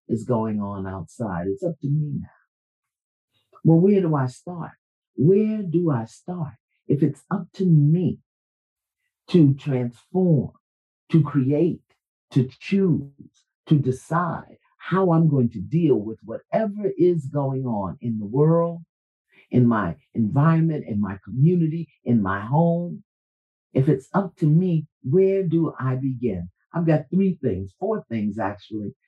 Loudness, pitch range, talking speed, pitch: -22 LUFS, 120-170 Hz, 140 wpm, 150 Hz